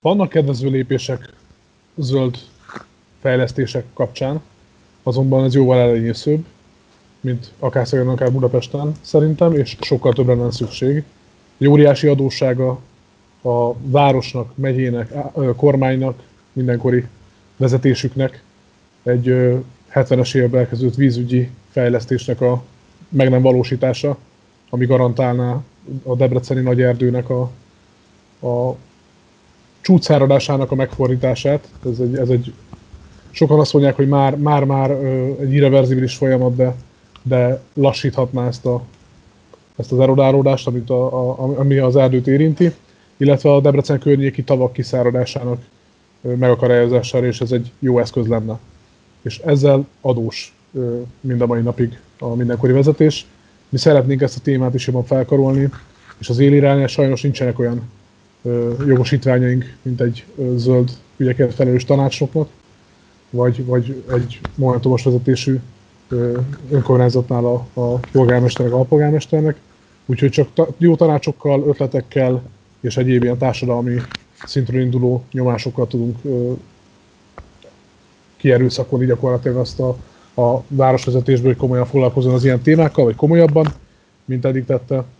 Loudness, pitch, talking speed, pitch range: -16 LUFS, 130 Hz, 115 wpm, 125-135 Hz